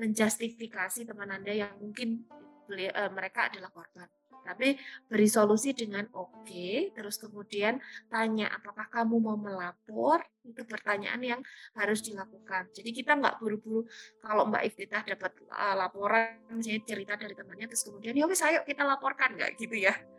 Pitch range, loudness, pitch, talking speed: 205-240 Hz, -31 LUFS, 215 Hz, 150 wpm